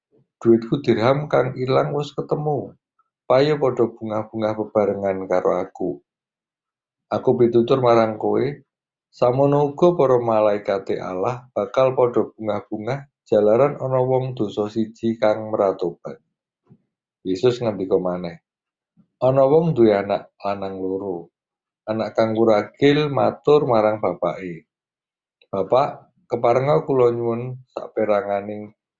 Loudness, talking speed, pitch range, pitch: -20 LUFS, 105 wpm, 105-130 Hz, 115 Hz